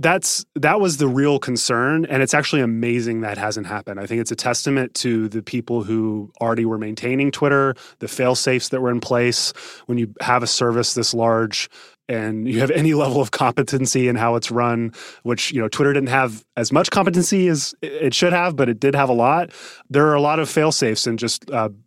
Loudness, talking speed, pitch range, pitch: -19 LUFS, 220 wpm, 115-145 Hz, 125 Hz